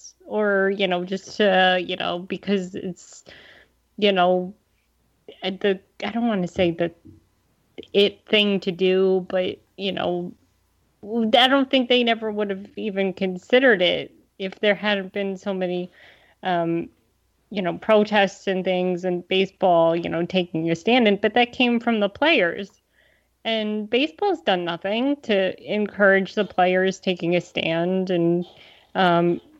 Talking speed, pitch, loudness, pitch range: 150 wpm, 195 Hz, -22 LUFS, 180-210 Hz